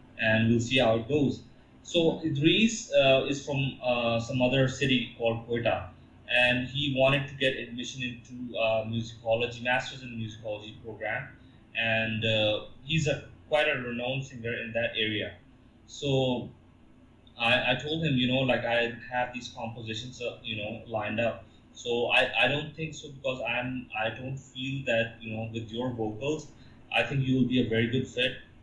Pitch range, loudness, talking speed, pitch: 115-130 Hz, -28 LUFS, 180 wpm, 125 Hz